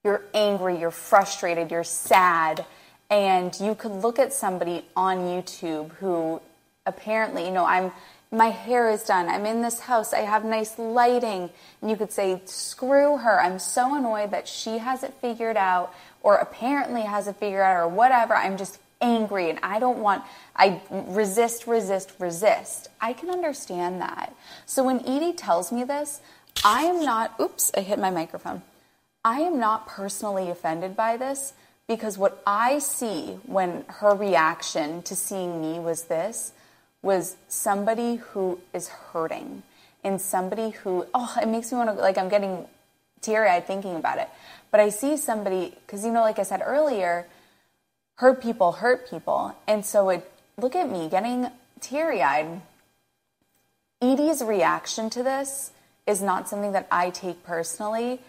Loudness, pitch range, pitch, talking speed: -25 LUFS, 185-240 Hz, 210 Hz, 165 wpm